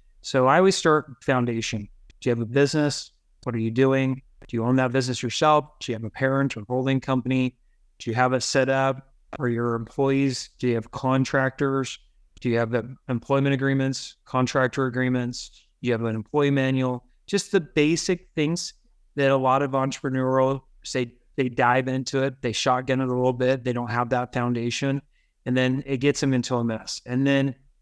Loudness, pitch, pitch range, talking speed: -24 LUFS, 130 Hz, 125-135 Hz, 190 wpm